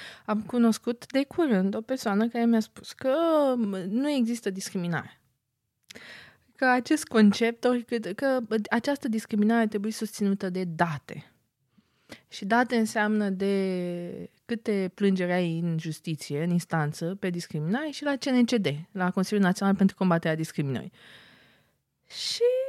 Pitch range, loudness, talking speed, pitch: 180-240 Hz, -27 LUFS, 125 wpm, 210 Hz